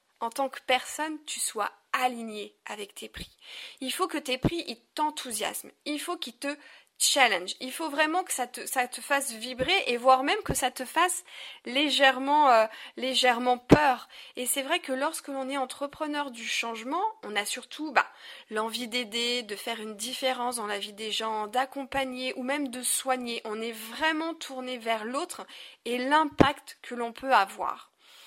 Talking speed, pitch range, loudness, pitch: 180 wpm, 235-295 Hz, -28 LUFS, 255 Hz